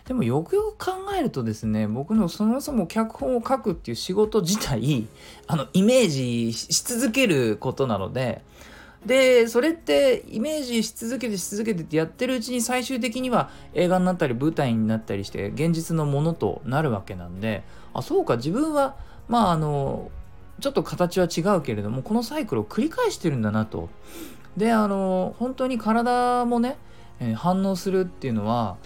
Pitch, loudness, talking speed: 190 Hz, -24 LUFS, 345 characters per minute